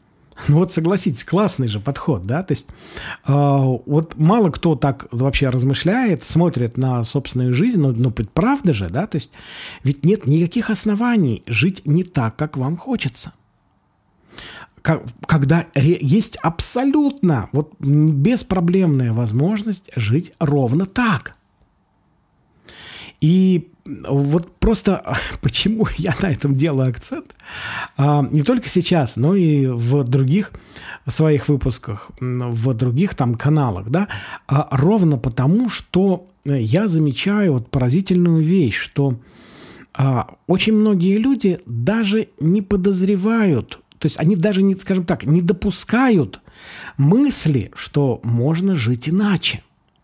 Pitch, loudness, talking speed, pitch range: 155 Hz, -18 LUFS, 120 wpm, 130-190 Hz